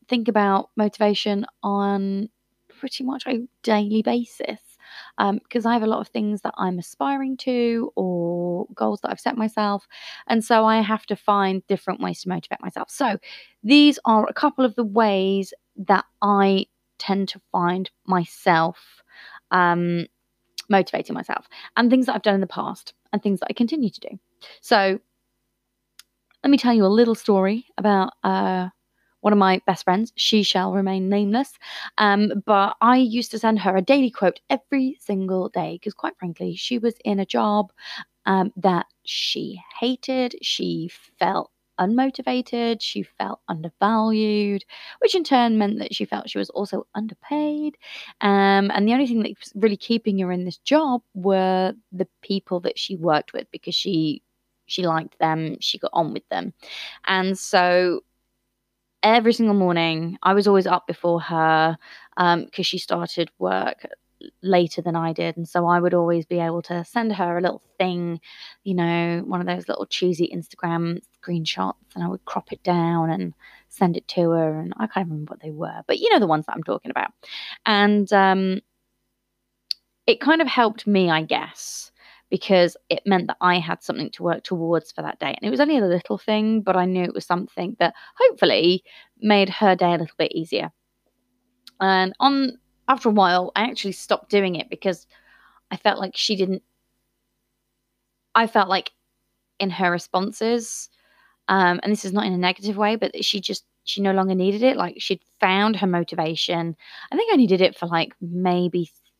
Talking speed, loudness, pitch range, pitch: 180 wpm, -22 LUFS, 180-225 Hz, 195 Hz